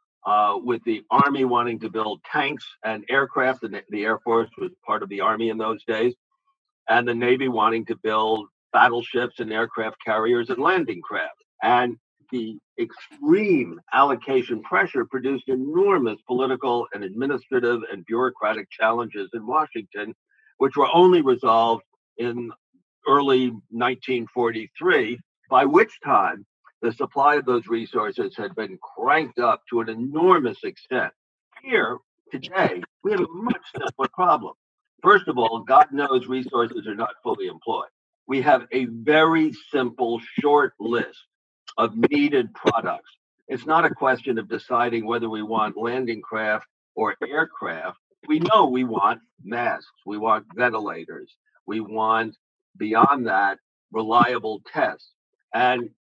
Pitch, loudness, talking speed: 125 Hz, -22 LUFS, 140 wpm